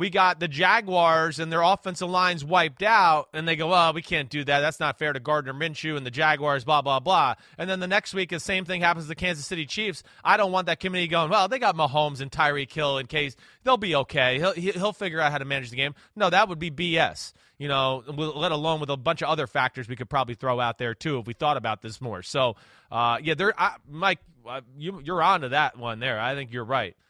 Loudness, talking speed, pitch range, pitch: -24 LUFS, 255 wpm, 135-180 Hz, 155 Hz